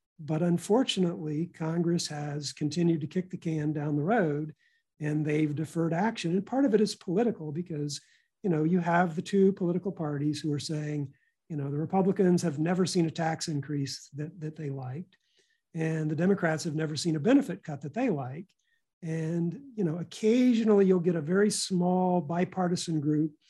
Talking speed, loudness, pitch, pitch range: 180 wpm, -29 LUFS, 170 Hz, 155-190 Hz